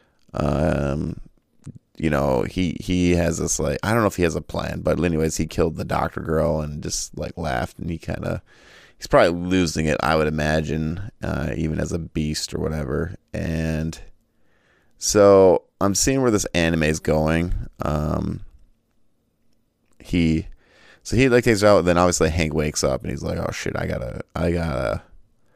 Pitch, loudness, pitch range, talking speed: 80 Hz, -22 LUFS, 75-90 Hz, 180 wpm